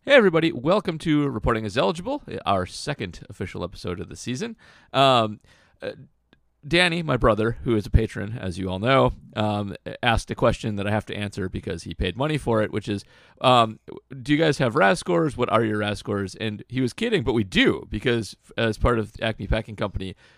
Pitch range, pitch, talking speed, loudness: 100-135 Hz, 110 Hz, 205 wpm, -23 LUFS